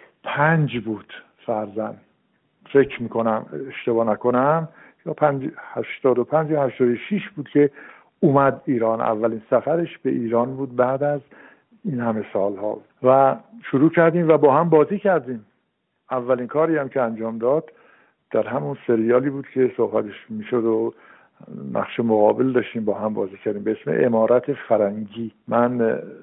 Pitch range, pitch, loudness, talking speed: 115-145 Hz, 125 Hz, -21 LUFS, 145 wpm